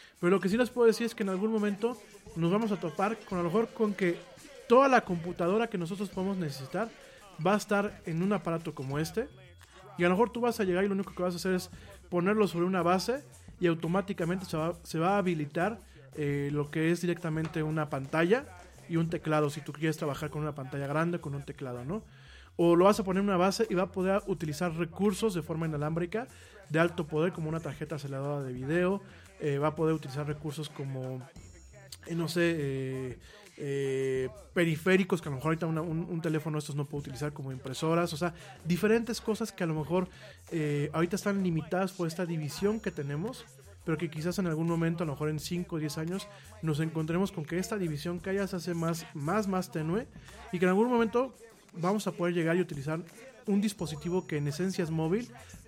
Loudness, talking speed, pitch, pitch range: -31 LUFS, 220 wpm, 170 Hz, 155-195 Hz